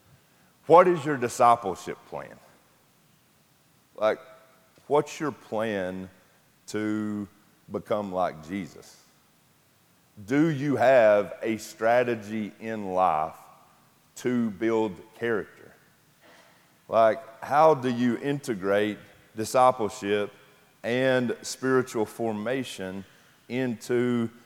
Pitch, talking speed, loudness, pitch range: 110 Hz, 80 wpm, -26 LUFS, 105-125 Hz